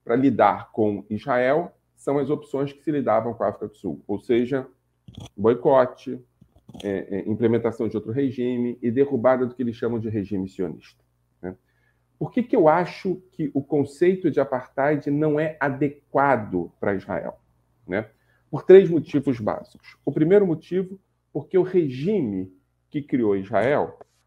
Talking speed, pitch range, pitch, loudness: 155 wpm, 100-150 Hz, 125 Hz, -23 LUFS